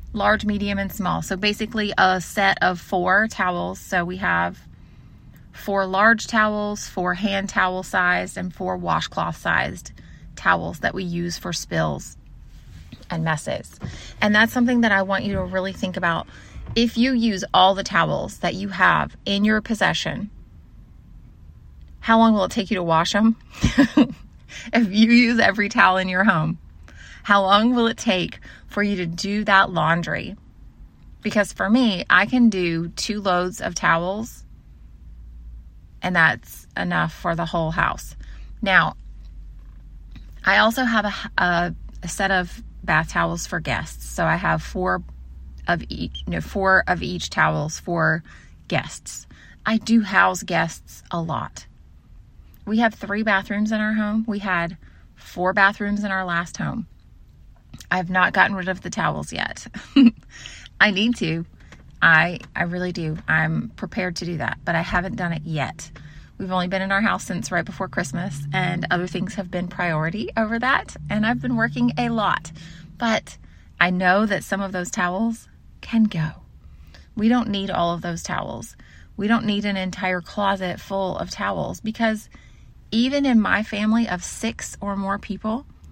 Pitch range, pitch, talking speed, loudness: 170-215 Hz, 190 Hz, 165 wpm, -21 LUFS